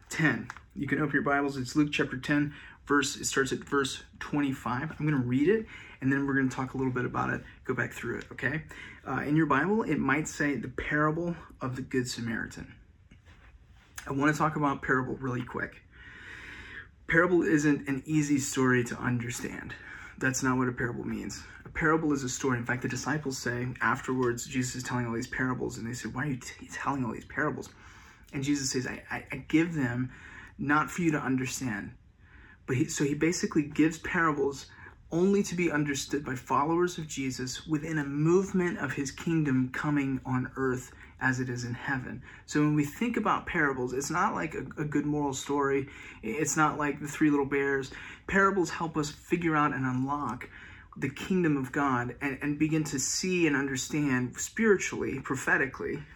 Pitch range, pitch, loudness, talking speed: 125-155 Hz, 140 Hz, -30 LUFS, 195 wpm